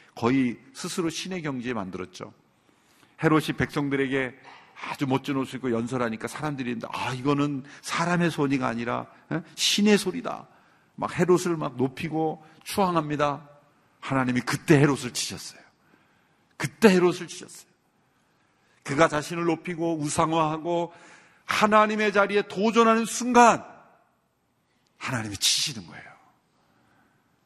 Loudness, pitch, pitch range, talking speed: -25 LUFS, 155 Hz, 135-175 Hz, 285 characters per minute